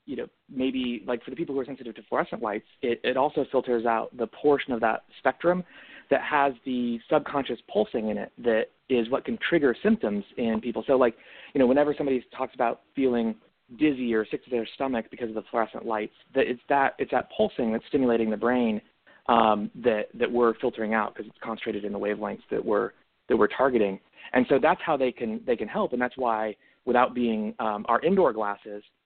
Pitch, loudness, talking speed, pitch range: 120 Hz, -27 LUFS, 215 wpm, 110-135 Hz